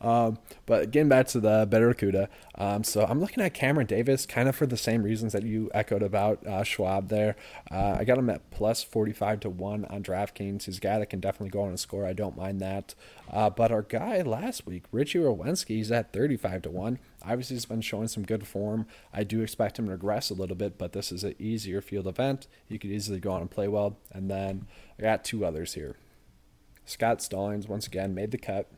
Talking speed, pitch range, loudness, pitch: 230 wpm, 100-115 Hz, -29 LUFS, 105 Hz